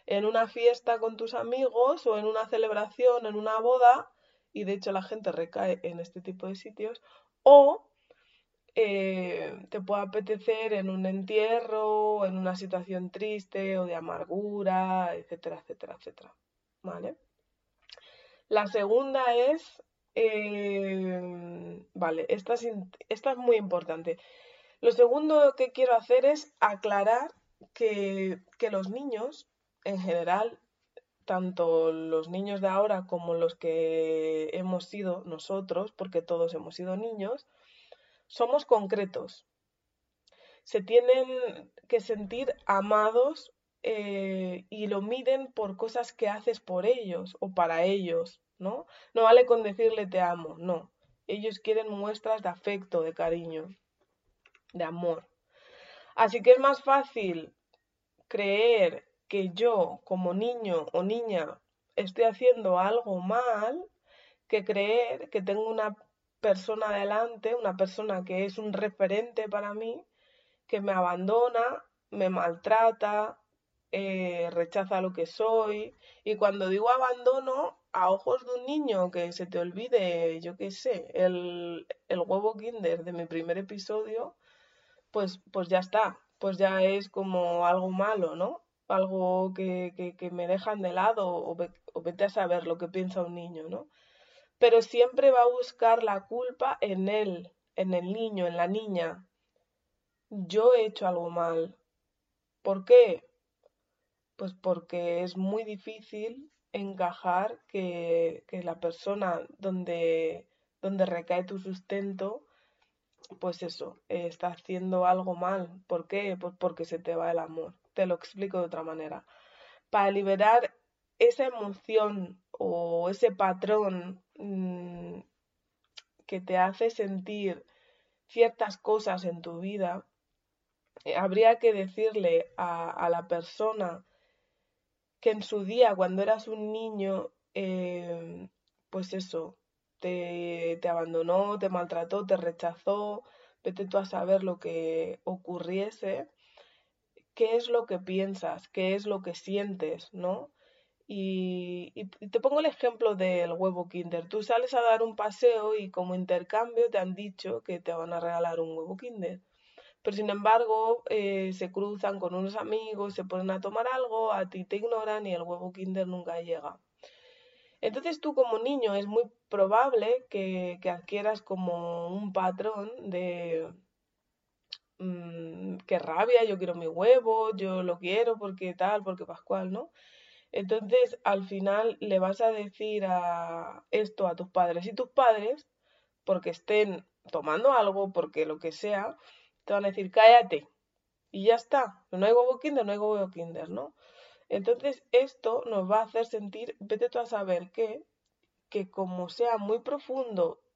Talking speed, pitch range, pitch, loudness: 140 wpm, 180-230 Hz, 200 Hz, -29 LUFS